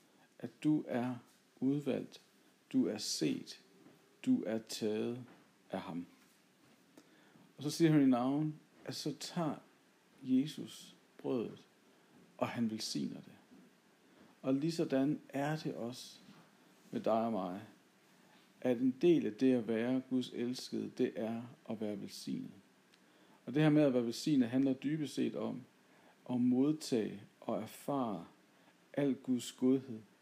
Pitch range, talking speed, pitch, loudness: 120-150 Hz, 135 wpm, 130 Hz, -36 LUFS